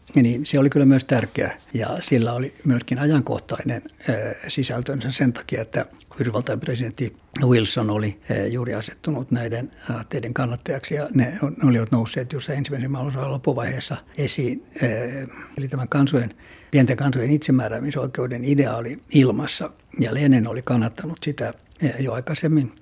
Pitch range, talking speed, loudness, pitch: 120-140 Hz, 130 wpm, -23 LUFS, 130 Hz